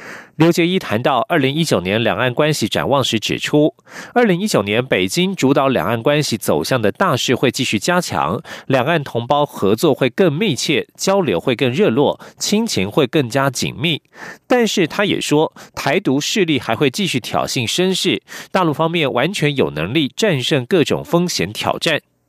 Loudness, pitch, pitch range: -17 LUFS, 155 Hz, 135-180 Hz